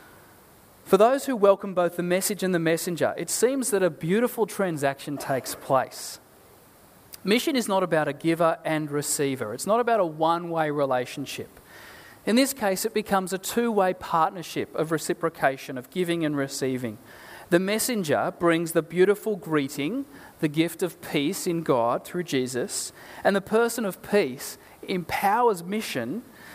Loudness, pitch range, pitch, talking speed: -25 LUFS, 155-205 Hz, 180 Hz, 155 wpm